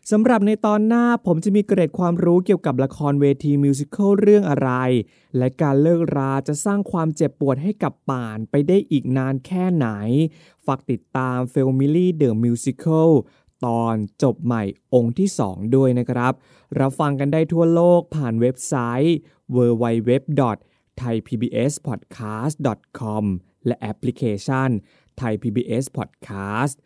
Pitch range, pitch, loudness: 120-165 Hz, 135 Hz, -20 LUFS